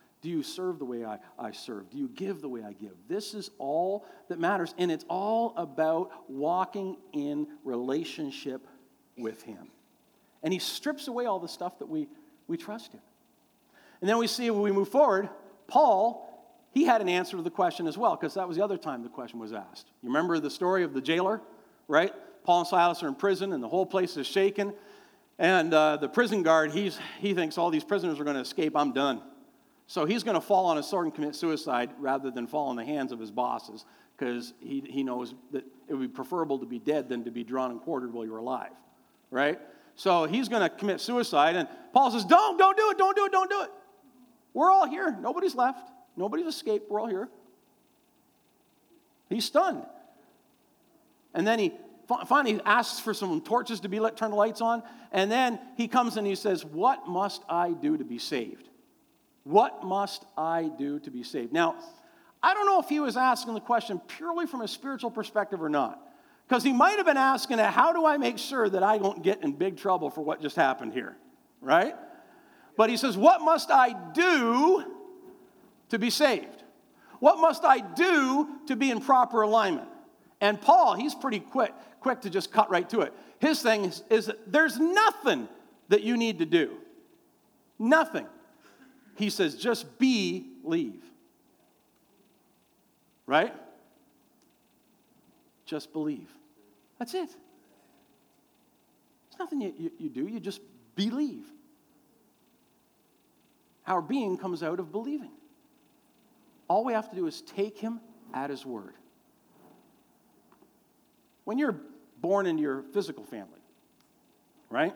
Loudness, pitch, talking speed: -28 LUFS, 230 Hz, 180 wpm